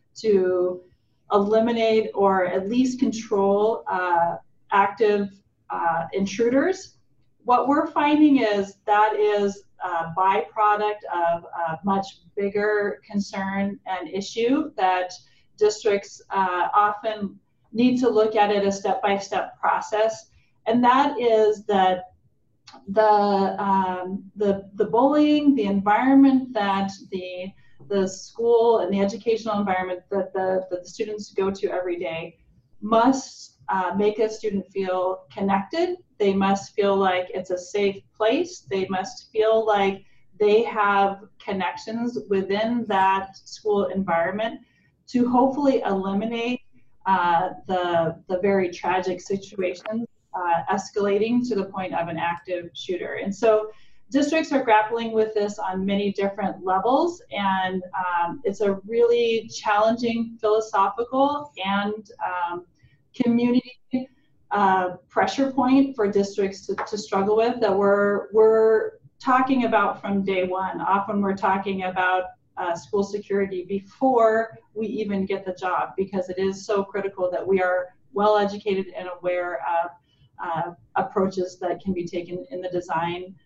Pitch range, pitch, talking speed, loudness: 185-220 Hz, 200 Hz, 130 wpm, -23 LUFS